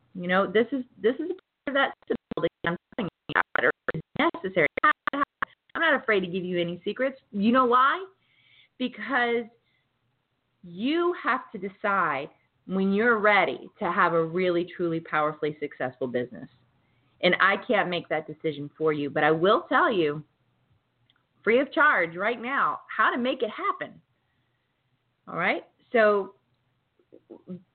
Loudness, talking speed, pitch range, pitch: -26 LUFS, 140 wpm, 150-245 Hz, 185 Hz